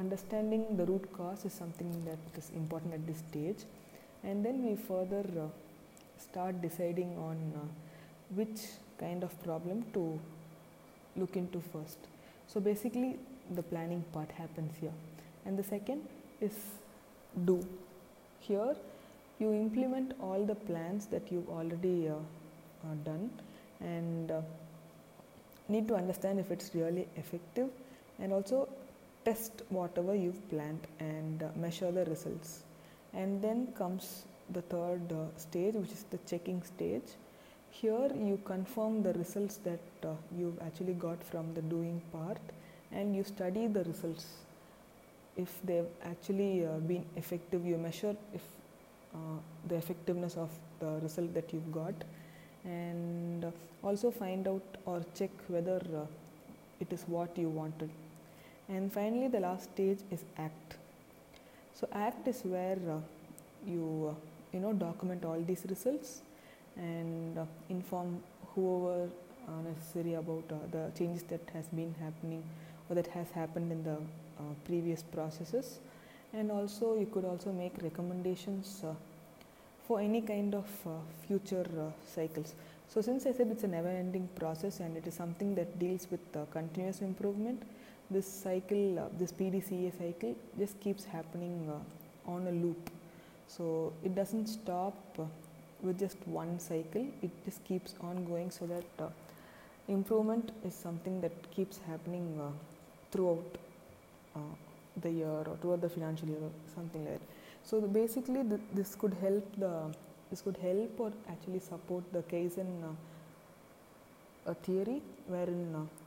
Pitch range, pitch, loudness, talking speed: 165-195 Hz, 175 Hz, -39 LUFS, 150 wpm